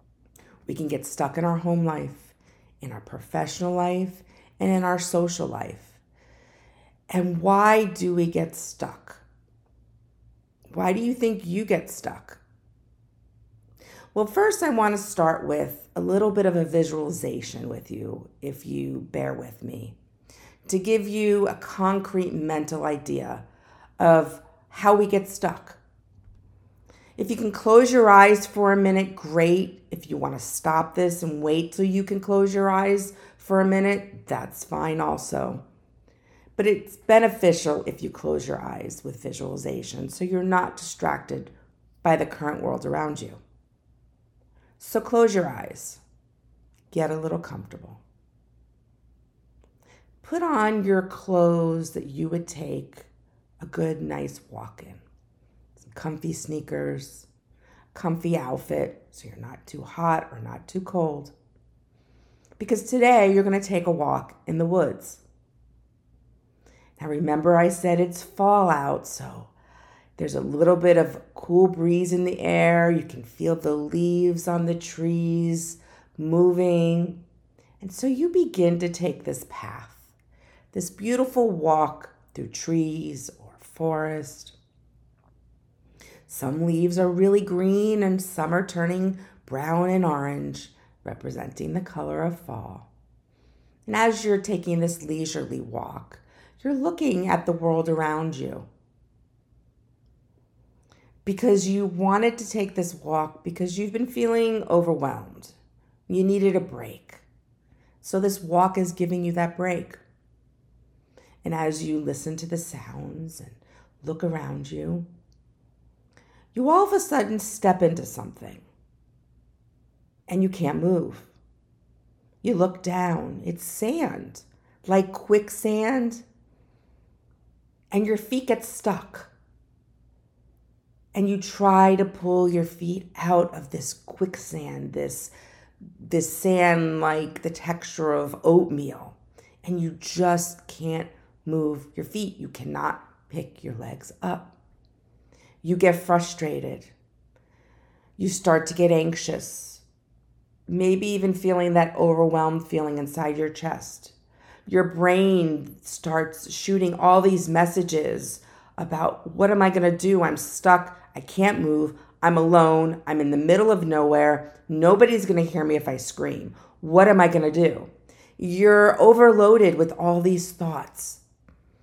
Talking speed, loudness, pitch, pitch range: 135 wpm, -23 LUFS, 170 Hz, 150-190 Hz